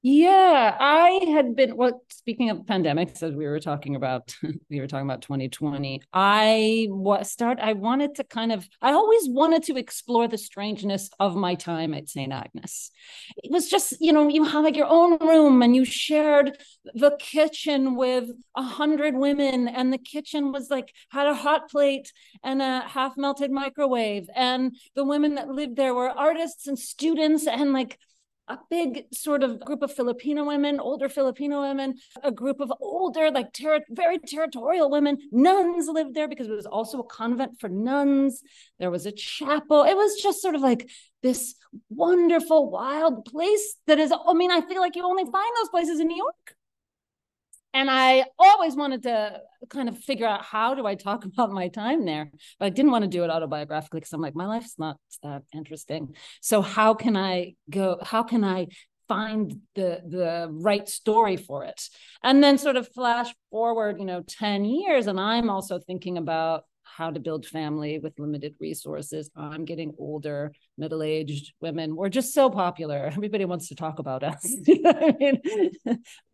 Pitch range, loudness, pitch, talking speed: 185-290 Hz, -24 LUFS, 250 Hz, 180 wpm